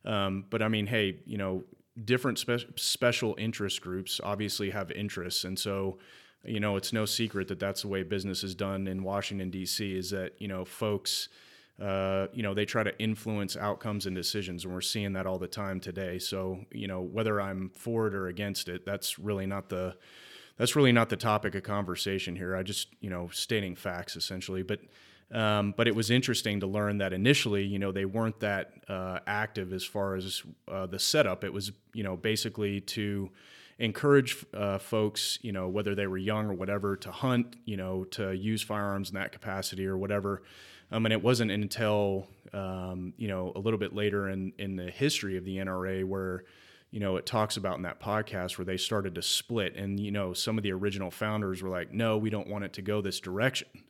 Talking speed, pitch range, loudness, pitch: 210 wpm, 95-105 Hz, -32 LUFS, 100 Hz